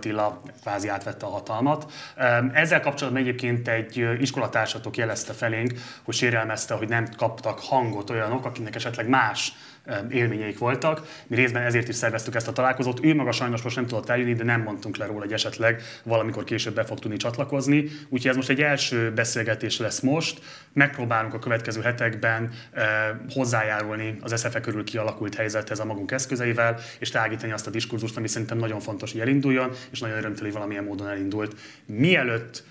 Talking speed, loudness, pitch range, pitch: 165 wpm, -25 LUFS, 110-130 Hz, 115 Hz